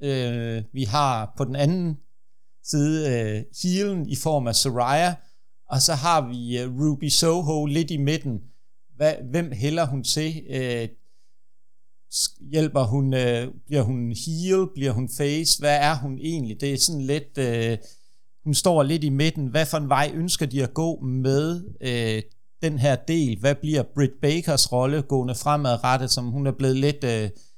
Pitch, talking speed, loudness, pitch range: 140 Hz, 170 wpm, -23 LUFS, 125-155 Hz